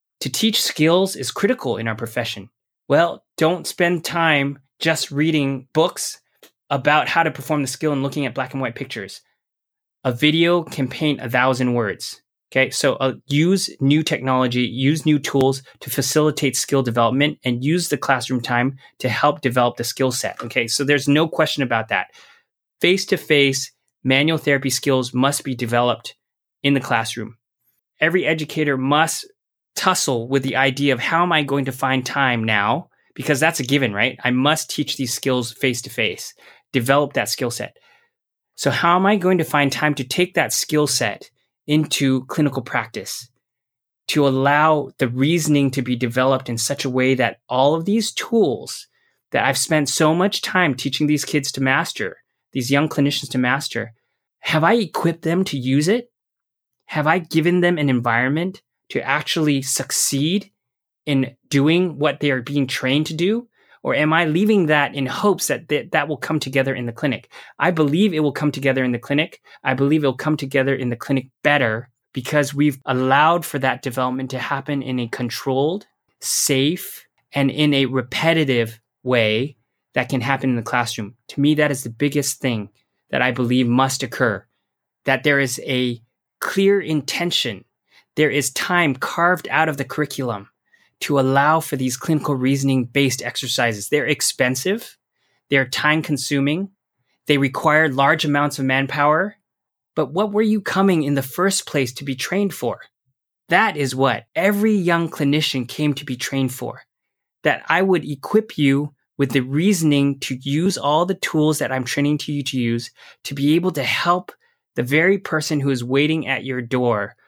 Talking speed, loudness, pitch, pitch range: 175 wpm, -19 LUFS, 140 Hz, 130-155 Hz